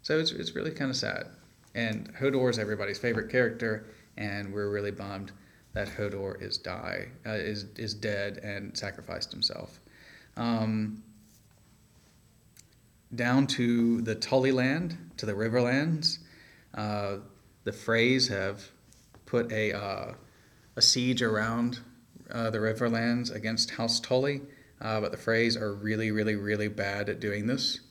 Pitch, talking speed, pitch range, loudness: 110 Hz, 140 wpm, 105-120 Hz, -30 LUFS